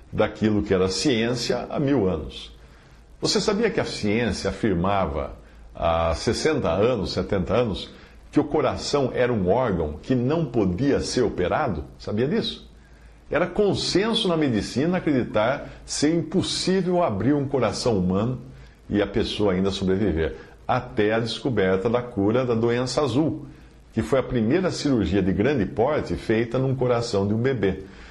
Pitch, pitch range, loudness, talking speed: 115 Hz, 95-135 Hz, -23 LUFS, 145 wpm